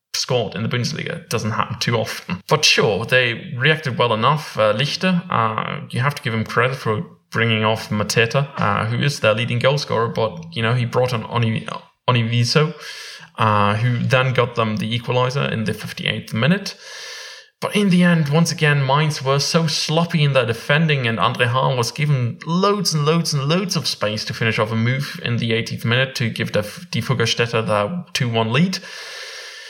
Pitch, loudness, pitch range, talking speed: 130 Hz, -19 LUFS, 115-165 Hz, 190 wpm